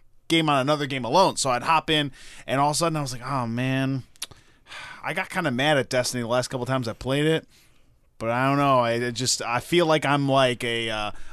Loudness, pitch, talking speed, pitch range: -23 LUFS, 130 Hz, 250 wpm, 120-150 Hz